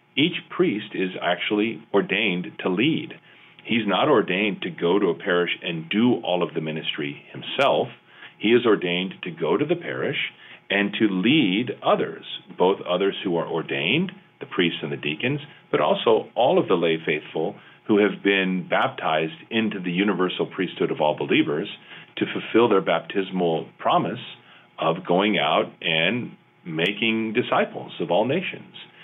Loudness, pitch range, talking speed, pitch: -23 LUFS, 85-110 Hz, 155 wpm, 95 Hz